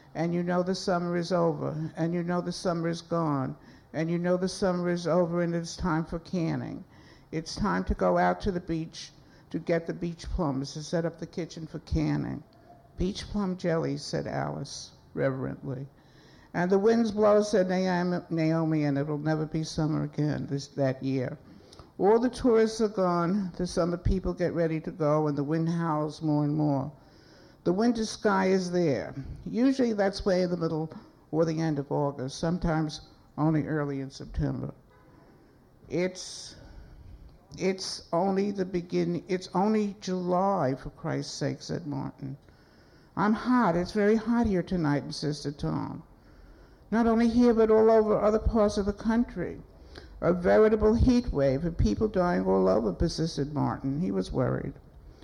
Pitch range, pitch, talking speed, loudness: 150-185 Hz, 170 Hz, 165 wpm, -28 LUFS